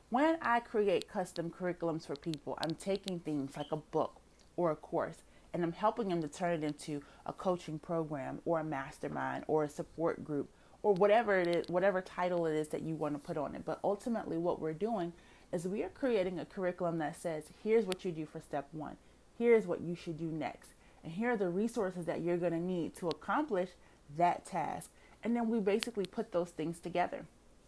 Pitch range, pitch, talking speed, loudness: 155-195 Hz, 170 Hz, 210 wpm, -36 LUFS